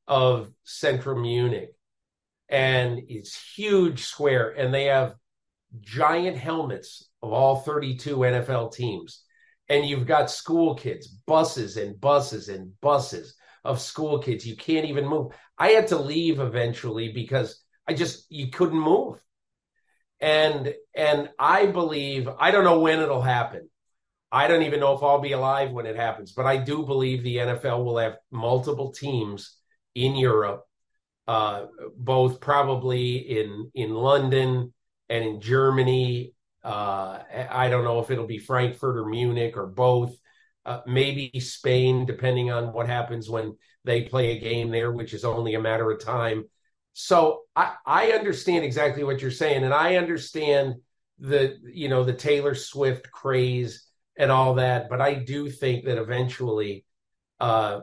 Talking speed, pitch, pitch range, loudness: 155 wpm, 130 Hz, 120-145 Hz, -24 LUFS